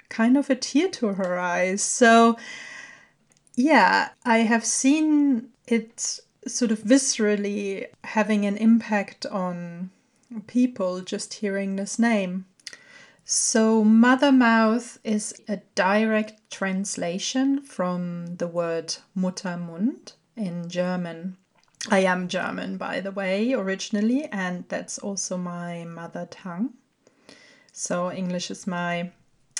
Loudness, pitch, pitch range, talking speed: -23 LUFS, 210 Hz, 185-240 Hz, 110 wpm